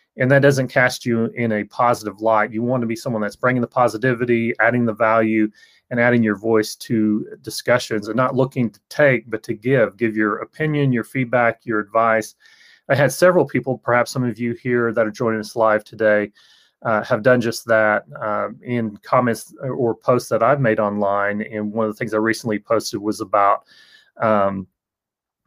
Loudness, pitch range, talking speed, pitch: -19 LUFS, 110-125 Hz, 195 wpm, 115 Hz